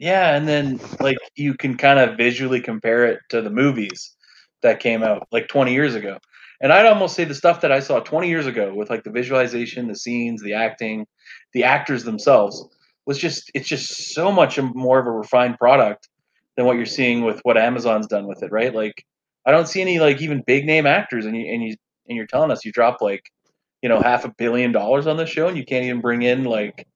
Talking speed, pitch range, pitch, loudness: 230 wpm, 120-145 Hz, 125 Hz, -19 LUFS